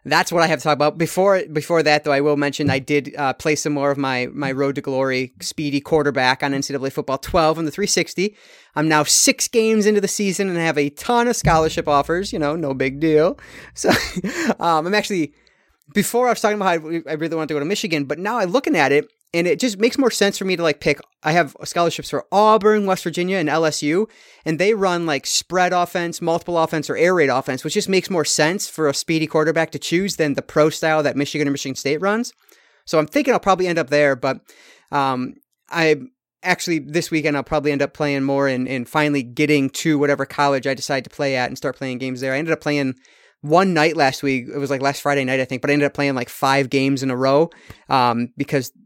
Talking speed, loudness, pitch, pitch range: 240 wpm, -19 LUFS, 150 Hz, 140-175 Hz